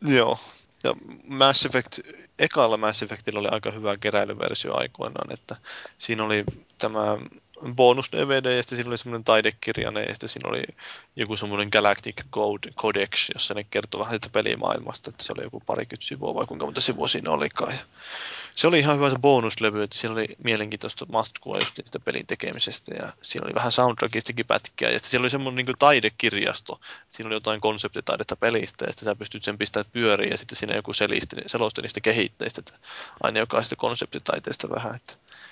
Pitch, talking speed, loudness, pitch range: 115 Hz, 175 wpm, -25 LUFS, 105-130 Hz